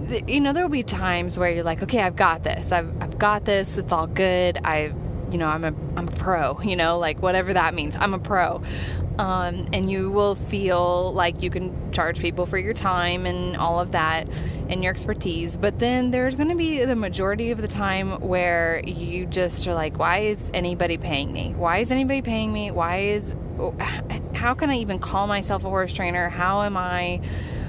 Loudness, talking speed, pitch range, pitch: -24 LUFS, 210 wpm, 160-205 Hz, 180 Hz